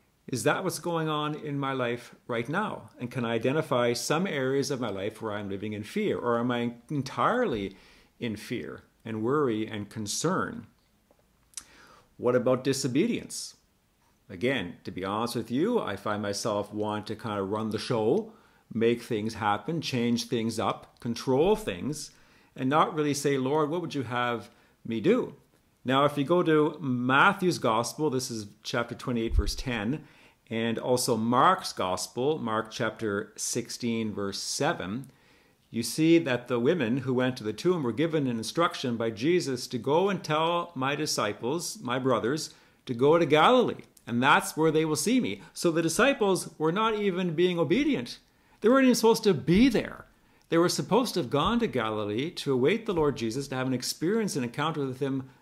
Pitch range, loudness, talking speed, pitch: 115-160 Hz, -28 LUFS, 180 wpm, 130 Hz